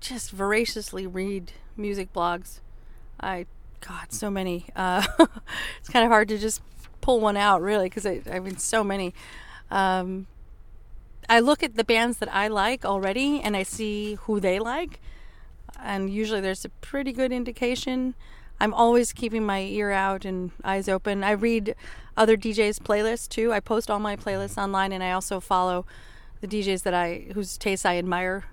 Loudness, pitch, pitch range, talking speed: -25 LUFS, 200 Hz, 190-225 Hz, 170 wpm